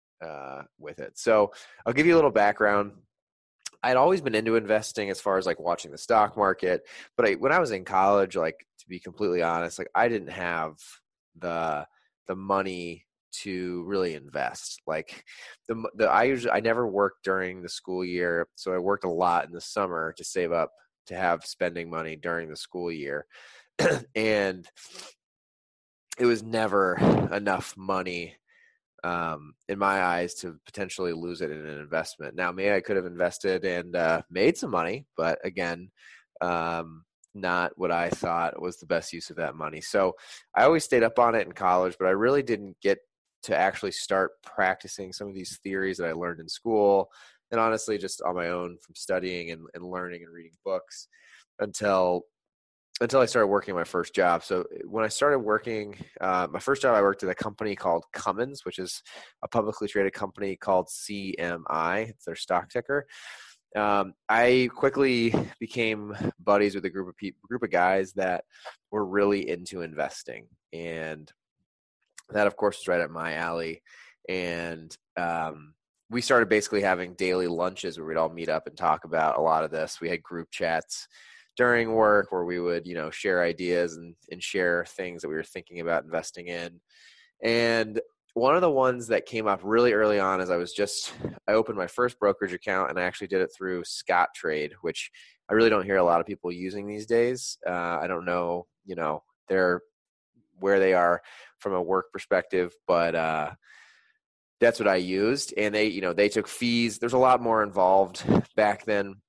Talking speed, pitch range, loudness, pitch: 185 wpm, 85-105 Hz, -27 LUFS, 95 Hz